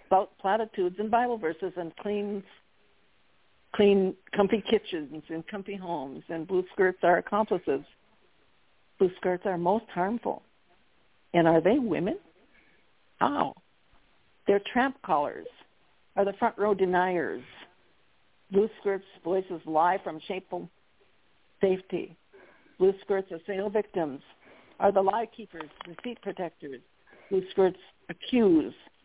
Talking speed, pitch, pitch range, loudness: 120 wpm, 195 Hz, 180-205 Hz, -28 LUFS